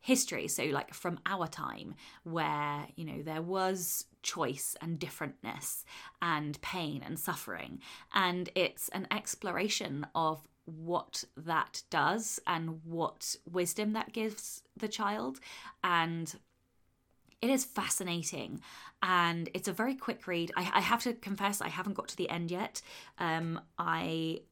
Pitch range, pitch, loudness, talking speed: 160-205 Hz, 180 Hz, -35 LUFS, 140 wpm